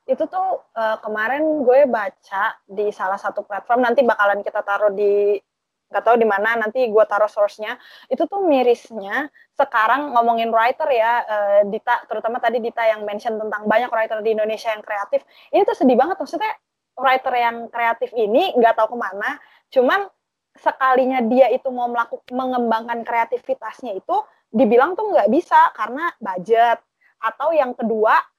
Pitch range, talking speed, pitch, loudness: 220-265 Hz, 155 wpm, 235 Hz, -19 LUFS